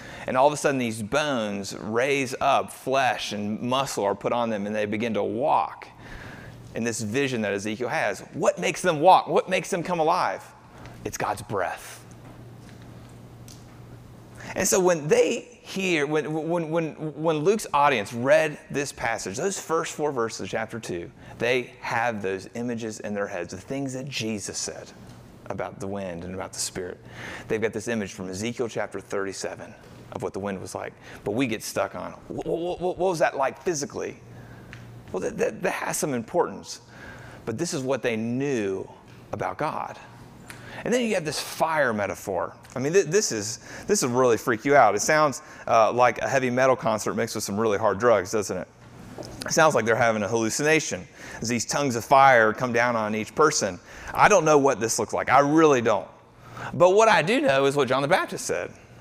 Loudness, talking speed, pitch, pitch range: -24 LUFS, 195 wpm, 120 Hz, 105-150 Hz